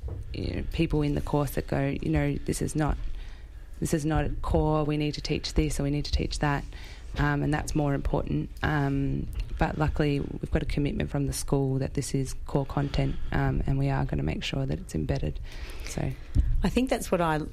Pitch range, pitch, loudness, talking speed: 135-150 Hz, 145 Hz, -29 LUFS, 225 wpm